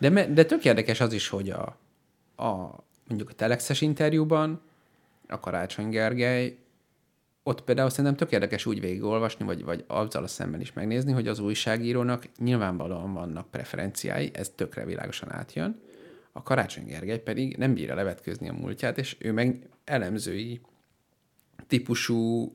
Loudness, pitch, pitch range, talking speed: -28 LUFS, 120 Hz, 110-130 Hz, 145 wpm